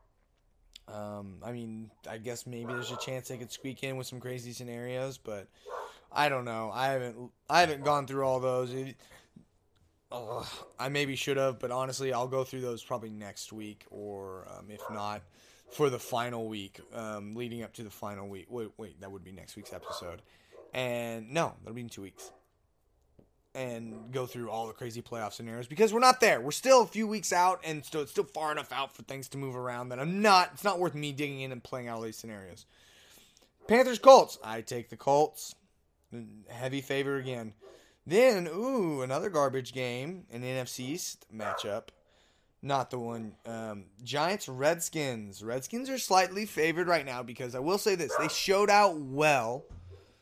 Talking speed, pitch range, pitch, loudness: 190 wpm, 115-145 Hz, 125 Hz, -30 LUFS